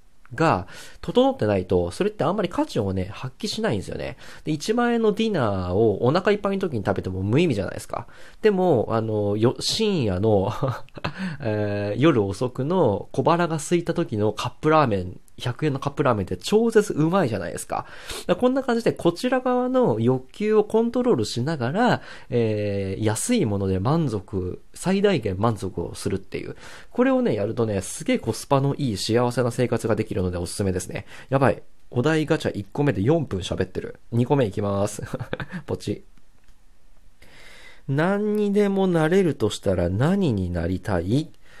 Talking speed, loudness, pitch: 340 characters per minute, -23 LUFS, 130 Hz